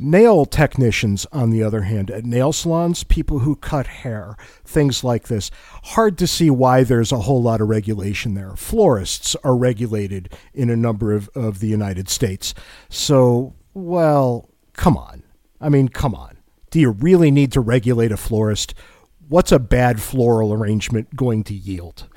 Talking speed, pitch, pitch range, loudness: 170 wpm, 120 Hz, 105-140 Hz, -18 LUFS